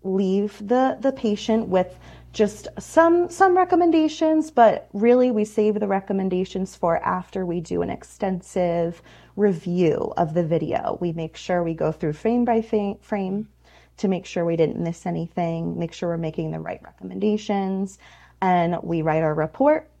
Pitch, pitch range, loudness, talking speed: 190 Hz, 170-220 Hz, -22 LUFS, 160 wpm